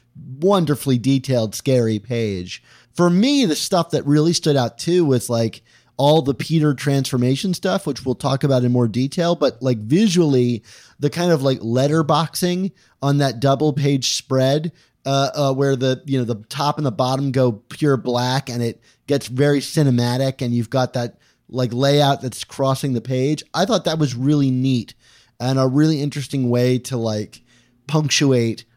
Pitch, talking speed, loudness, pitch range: 135 Hz, 175 wpm, -19 LUFS, 125-150 Hz